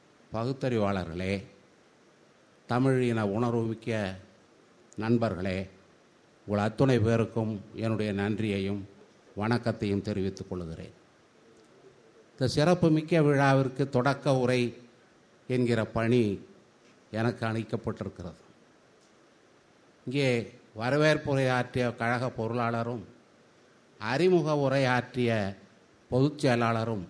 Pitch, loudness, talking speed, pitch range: 115 Hz, -29 LUFS, 70 wpm, 105-125 Hz